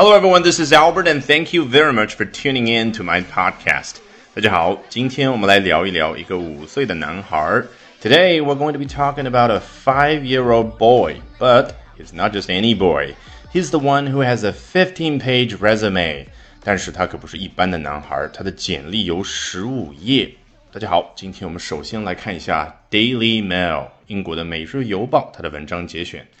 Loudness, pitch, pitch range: -17 LUFS, 115 Hz, 90-140 Hz